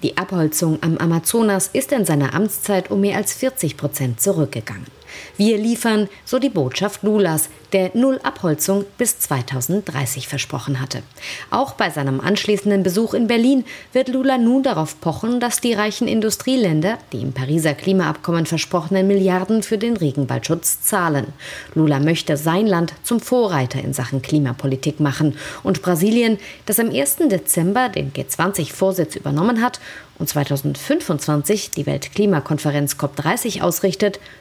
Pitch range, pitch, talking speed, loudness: 150-215 Hz, 180 Hz, 140 wpm, -19 LUFS